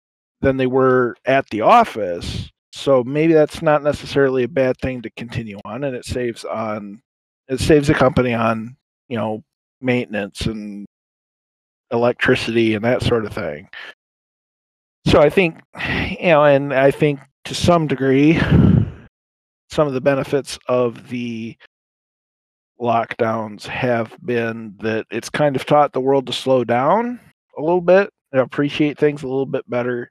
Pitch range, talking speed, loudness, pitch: 115-140 Hz, 150 wpm, -18 LUFS, 130 Hz